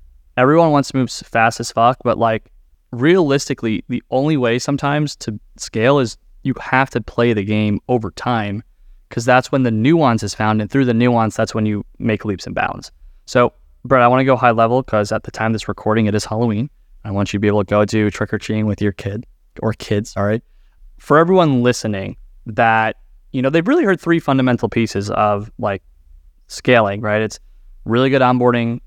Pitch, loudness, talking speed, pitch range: 115 Hz, -17 LUFS, 205 wpm, 105-125 Hz